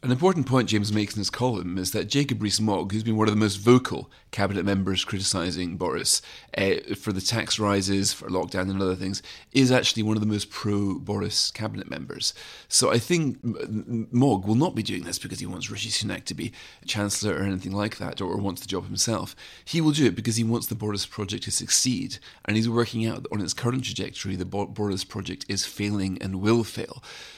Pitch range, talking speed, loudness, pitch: 95-115 Hz, 220 wpm, -25 LUFS, 105 Hz